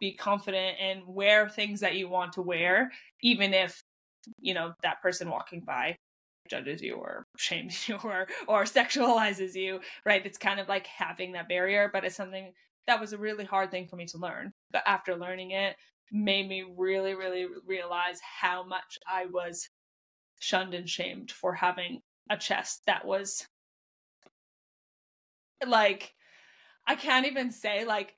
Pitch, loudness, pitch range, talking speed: 190 Hz, -30 LUFS, 180-205 Hz, 165 wpm